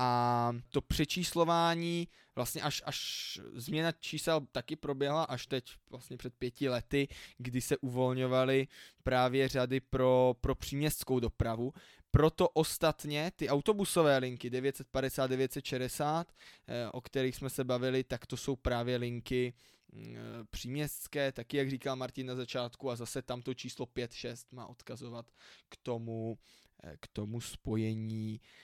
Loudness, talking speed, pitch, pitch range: -34 LUFS, 130 wpm, 130 Hz, 120-140 Hz